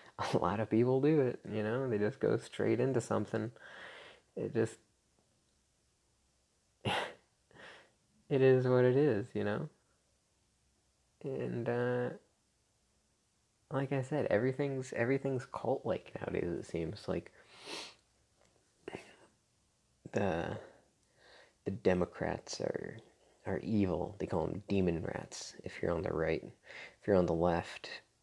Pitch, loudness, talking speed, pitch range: 110 Hz, -35 LUFS, 120 wpm, 100-130 Hz